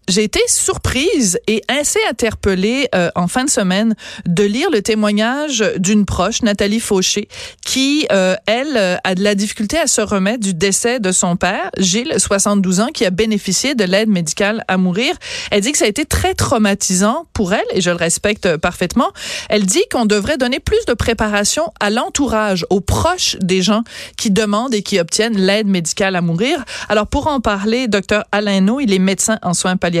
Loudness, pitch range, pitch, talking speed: -15 LUFS, 195-240 Hz, 210 Hz, 195 wpm